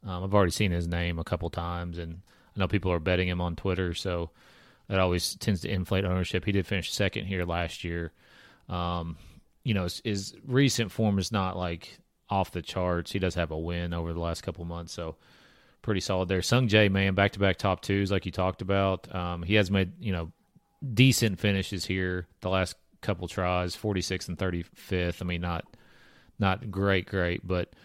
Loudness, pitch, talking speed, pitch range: -29 LUFS, 95 Hz, 195 wpm, 85-100 Hz